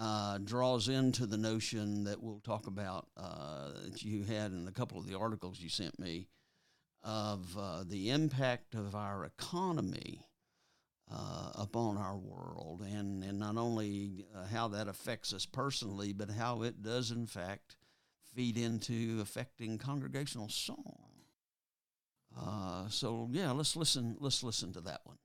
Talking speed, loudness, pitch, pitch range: 150 wpm, -39 LUFS, 110 Hz, 100-120 Hz